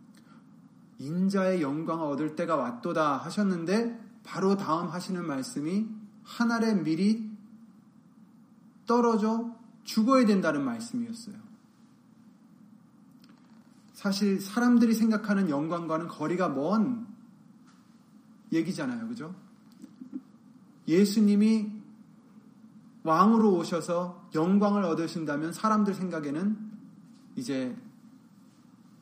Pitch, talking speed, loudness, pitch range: 220 Hz, 205 characters per minute, -28 LUFS, 190-230 Hz